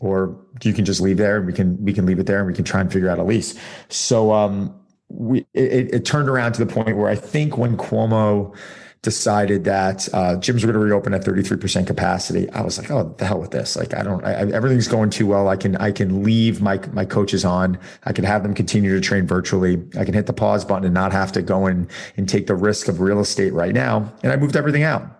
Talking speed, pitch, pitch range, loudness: 265 wpm, 100 Hz, 95-110 Hz, -19 LUFS